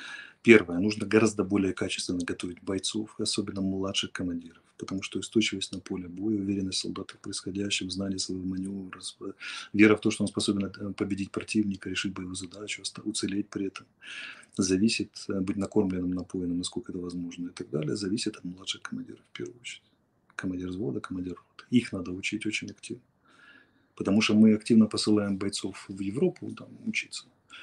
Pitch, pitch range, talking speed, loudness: 100 Hz, 95-105 Hz, 160 wpm, -29 LUFS